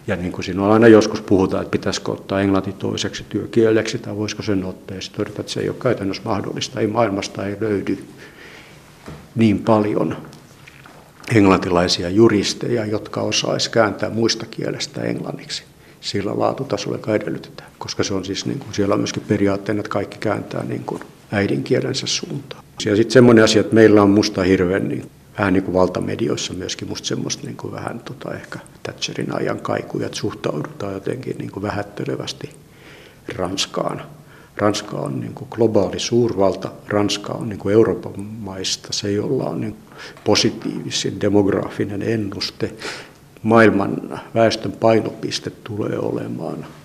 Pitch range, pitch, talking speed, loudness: 100-110 Hz, 105 Hz, 145 wpm, -19 LUFS